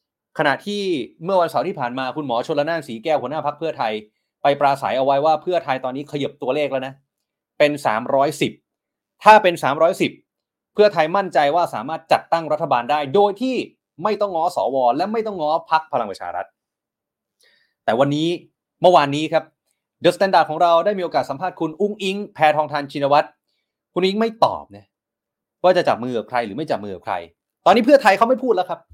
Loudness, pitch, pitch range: -19 LUFS, 155 Hz, 140-185 Hz